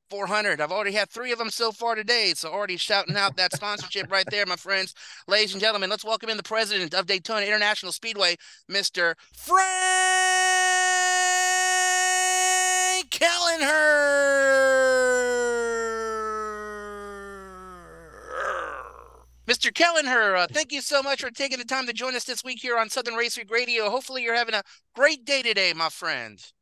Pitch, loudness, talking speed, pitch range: 230 Hz, -23 LUFS, 150 wpm, 200-280 Hz